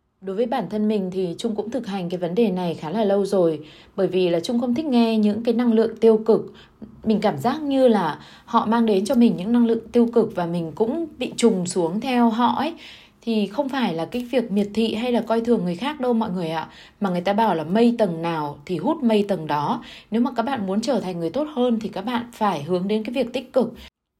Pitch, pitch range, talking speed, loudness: 220 Hz, 190-240 Hz, 265 wpm, -22 LUFS